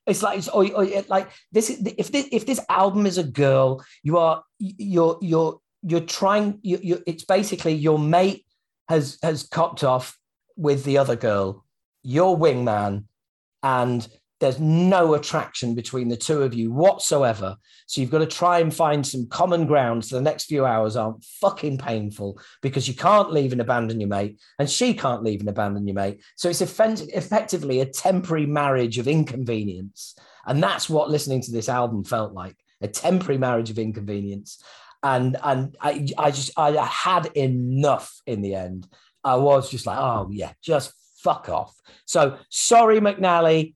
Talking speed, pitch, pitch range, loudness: 175 wpm, 145 Hz, 120-175 Hz, -22 LUFS